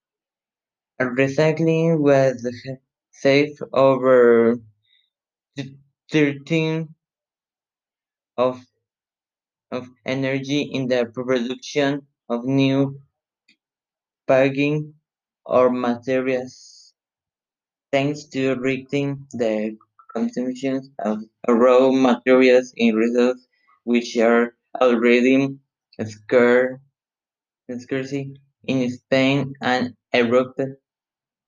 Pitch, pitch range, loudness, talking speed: 130 Hz, 125-140 Hz, -20 LUFS, 65 wpm